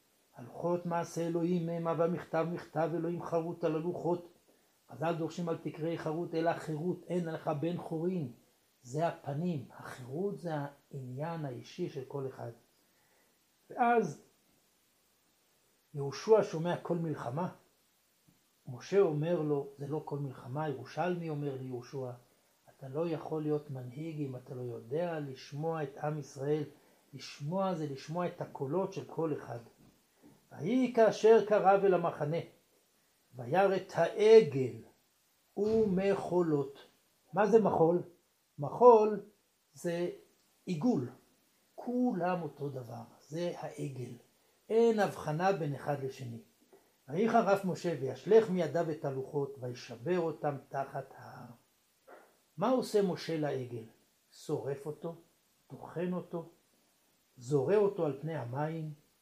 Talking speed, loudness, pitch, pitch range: 120 wpm, -33 LUFS, 160 Hz, 140-175 Hz